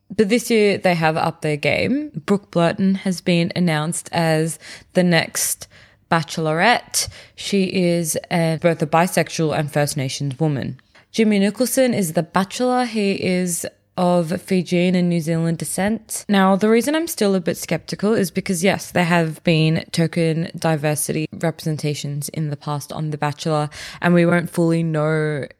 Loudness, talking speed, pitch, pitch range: -19 LUFS, 160 wpm, 170 Hz, 160-190 Hz